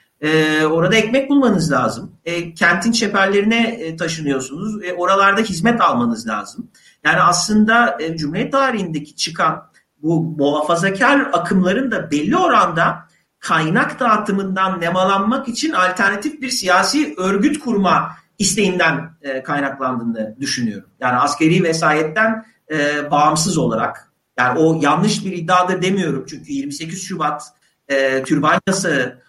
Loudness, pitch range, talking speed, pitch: -17 LUFS, 155-220 Hz, 115 wpm, 185 Hz